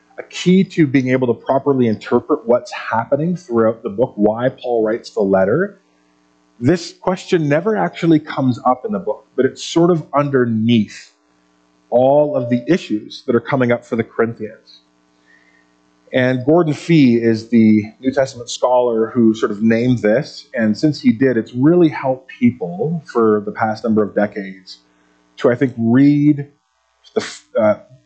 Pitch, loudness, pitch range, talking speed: 120 Hz, -16 LUFS, 105-145 Hz, 160 wpm